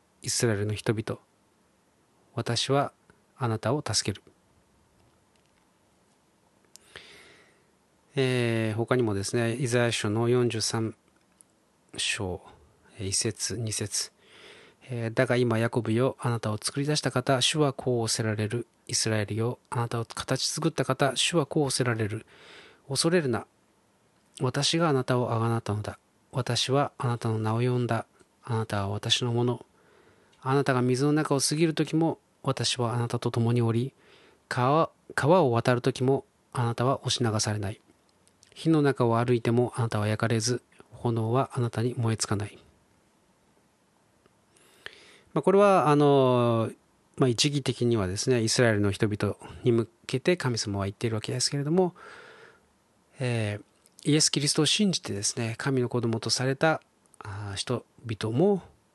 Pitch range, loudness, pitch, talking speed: 110-135 Hz, -27 LUFS, 120 Hz, 265 characters per minute